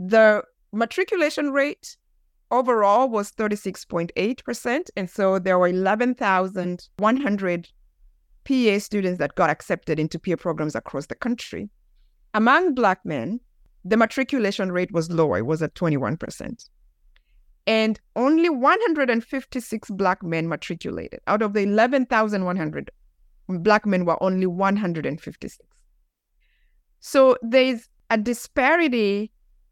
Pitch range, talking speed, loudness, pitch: 180-245 Hz, 105 wpm, -22 LUFS, 210 Hz